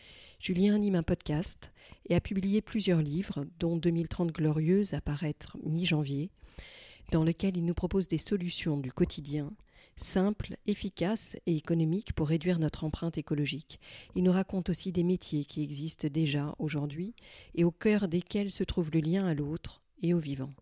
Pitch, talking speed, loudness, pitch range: 170 Hz, 165 wpm, -31 LUFS, 155-190 Hz